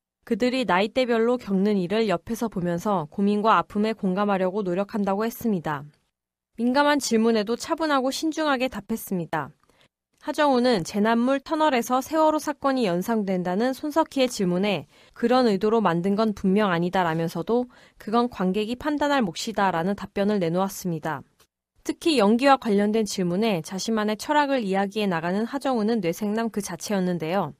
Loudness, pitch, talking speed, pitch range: -24 LUFS, 215 Hz, 360 characters per minute, 190-250 Hz